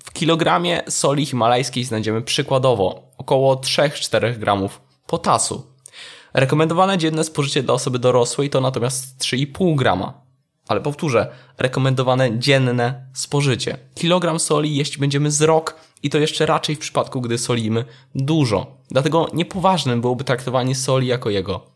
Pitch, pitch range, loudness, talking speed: 135 Hz, 125-155 Hz, -19 LUFS, 125 wpm